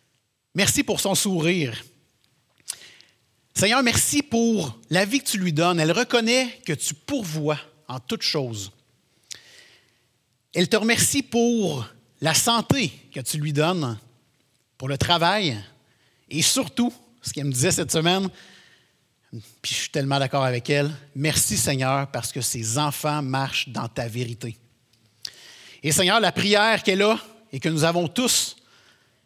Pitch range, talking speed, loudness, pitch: 125-190 Hz, 145 wpm, -22 LUFS, 150 Hz